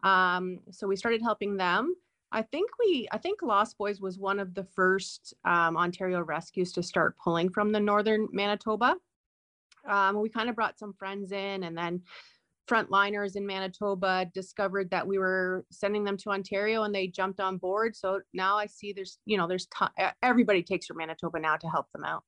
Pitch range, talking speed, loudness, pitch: 185-210 Hz, 195 wpm, -29 LUFS, 195 Hz